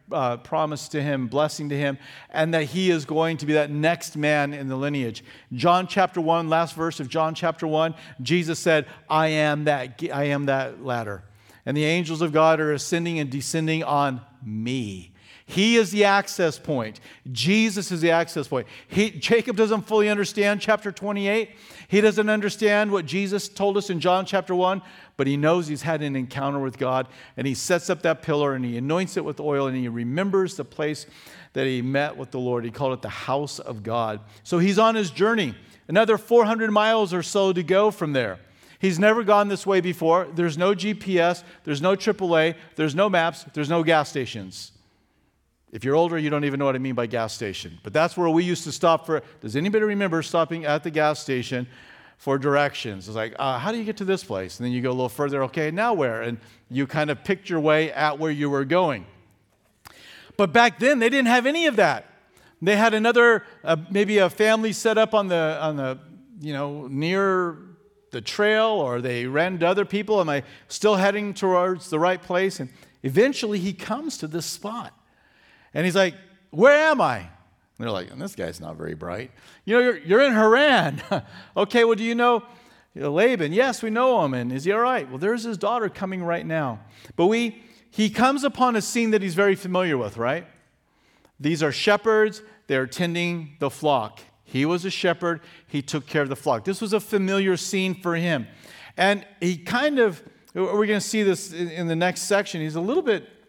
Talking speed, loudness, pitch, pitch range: 205 wpm, -23 LUFS, 165 Hz, 140-200 Hz